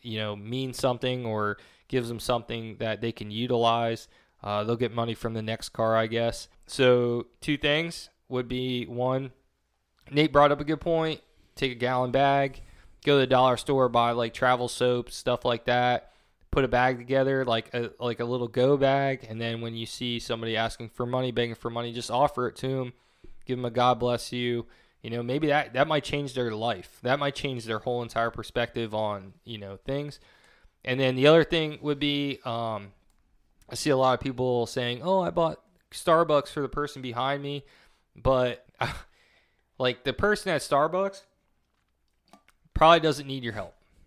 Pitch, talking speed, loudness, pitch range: 125 Hz, 190 wpm, -27 LUFS, 115-135 Hz